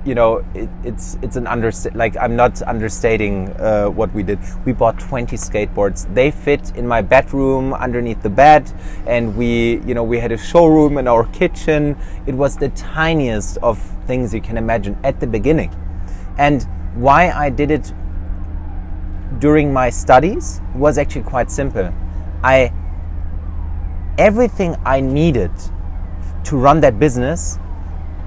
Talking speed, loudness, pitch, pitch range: 145 wpm, -16 LUFS, 115 Hz, 80-135 Hz